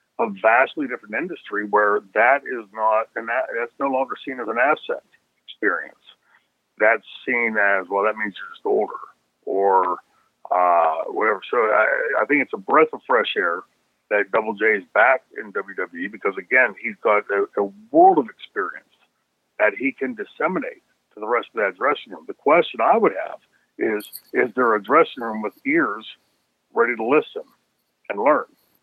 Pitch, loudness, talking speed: 390 Hz, -21 LUFS, 175 wpm